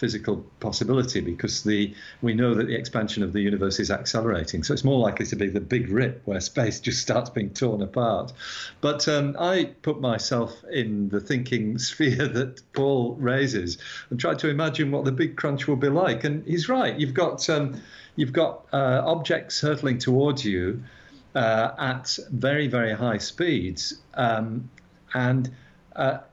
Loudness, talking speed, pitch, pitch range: -25 LUFS, 170 wpm, 125 Hz, 110-140 Hz